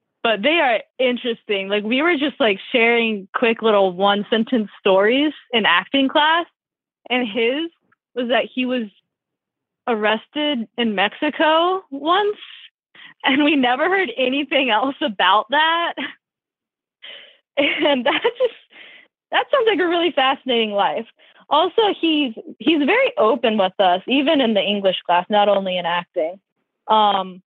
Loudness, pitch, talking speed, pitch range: -18 LUFS, 255 Hz, 140 wpm, 210-310 Hz